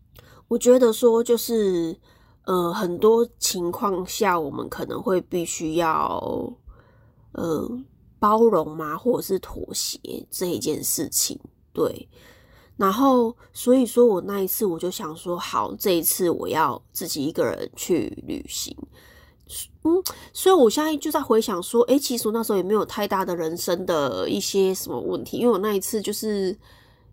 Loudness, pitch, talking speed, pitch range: -23 LUFS, 205 Hz, 230 characters per minute, 175-235 Hz